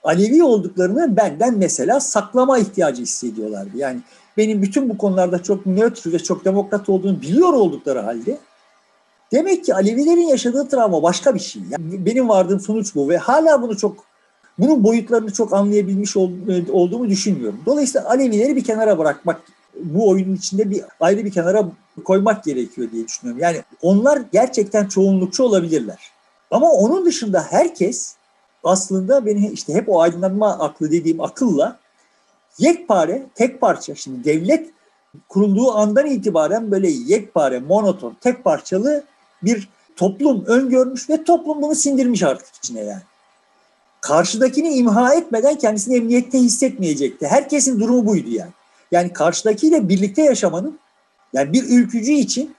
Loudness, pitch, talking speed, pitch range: -17 LUFS, 210 Hz, 135 wpm, 185-255 Hz